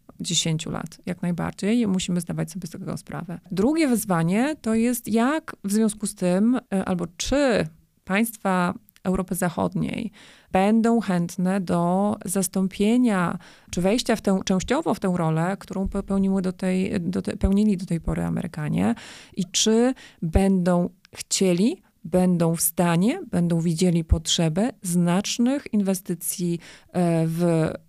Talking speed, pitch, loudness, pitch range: 130 wpm, 190 Hz, -23 LUFS, 175-220 Hz